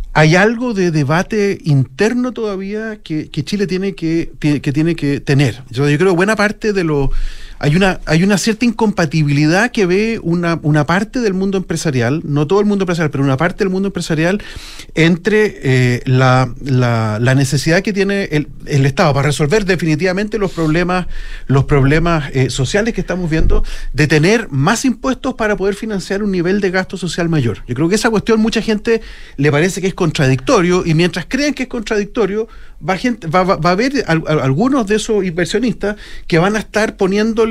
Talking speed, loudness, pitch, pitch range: 185 wpm, -15 LUFS, 180 Hz, 150-210 Hz